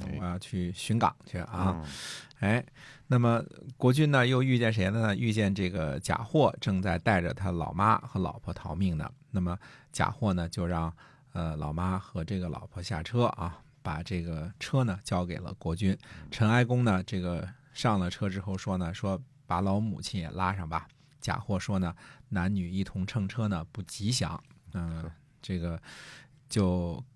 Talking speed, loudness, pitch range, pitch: 235 characters per minute, -31 LUFS, 90-120 Hz, 95 Hz